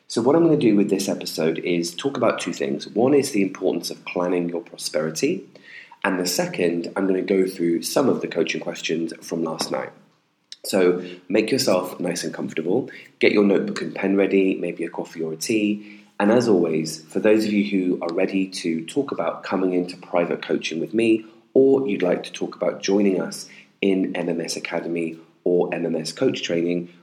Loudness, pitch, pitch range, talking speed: -22 LUFS, 90 Hz, 85-100 Hz, 200 wpm